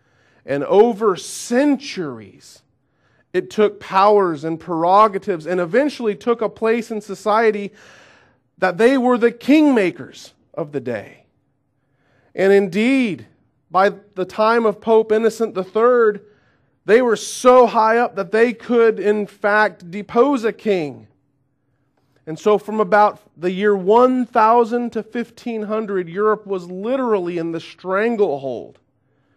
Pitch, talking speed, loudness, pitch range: 205 Hz, 125 wpm, -17 LUFS, 160-225 Hz